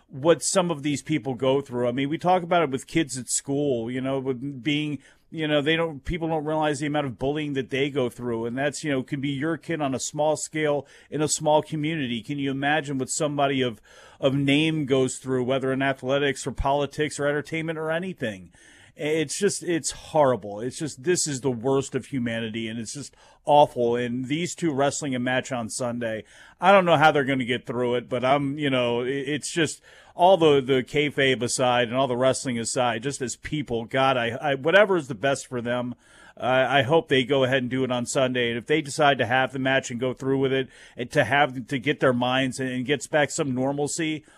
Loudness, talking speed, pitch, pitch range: -24 LUFS, 230 wpm, 140 Hz, 130-150 Hz